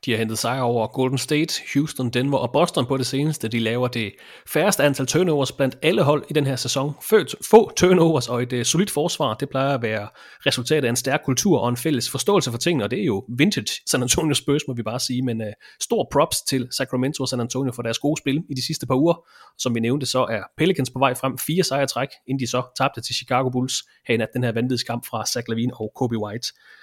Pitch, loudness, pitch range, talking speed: 130 Hz, -22 LUFS, 120-145 Hz, 245 wpm